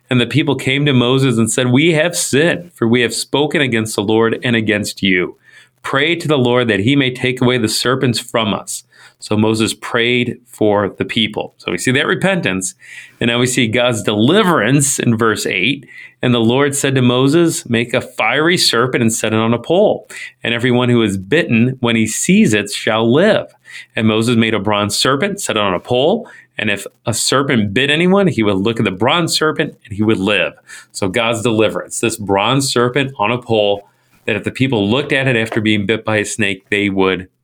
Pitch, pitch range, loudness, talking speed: 115 Hz, 110-130 Hz, -15 LUFS, 215 wpm